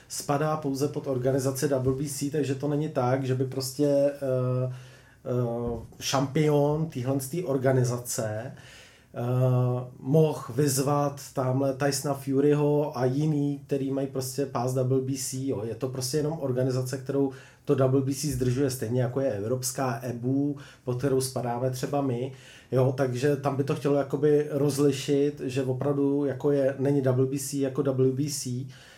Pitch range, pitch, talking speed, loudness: 130-145 Hz, 135 Hz, 135 wpm, -27 LUFS